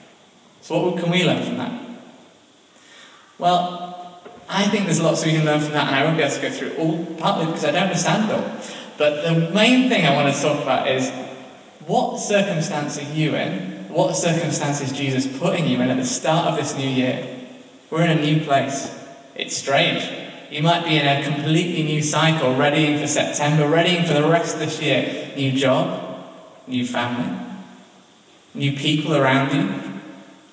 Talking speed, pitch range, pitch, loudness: 185 wpm, 140-175 Hz, 155 Hz, -20 LUFS